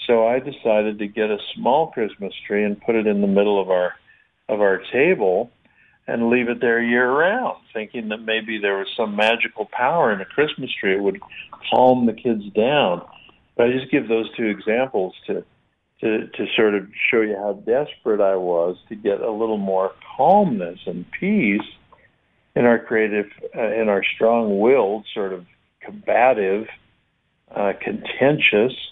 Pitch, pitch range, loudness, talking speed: 110 Hz, 100-120 Hz, -20 LUFS, 170 wpm